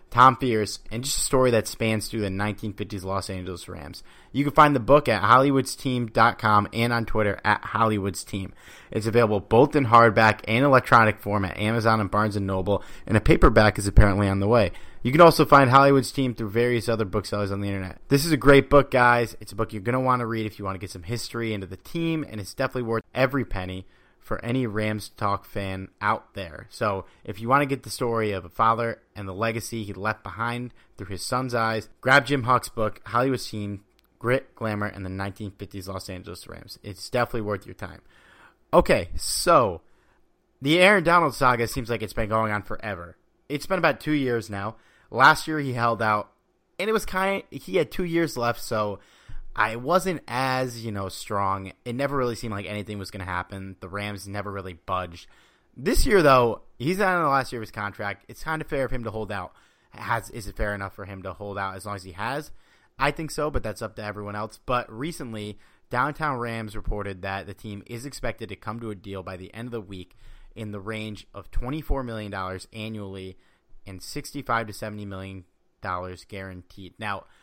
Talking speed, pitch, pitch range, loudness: 215 wpm, 110 Hz, 100-125 Hz, -24 LUFS